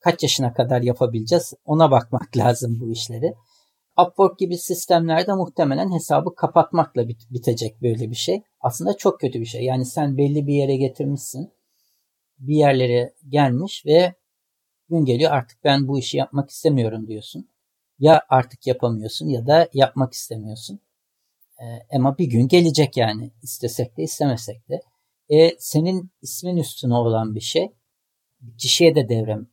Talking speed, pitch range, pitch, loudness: 140 wpm, 120-160 Hz, 135 Hz, -20 LUFS